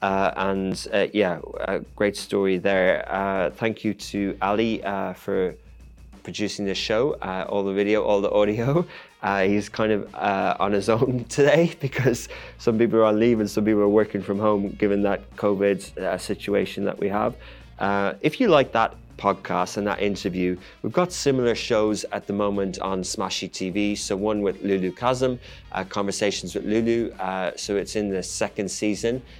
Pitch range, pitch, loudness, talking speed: 95-110 Hz, 100 Hz, -24 LUFS, 180 wpm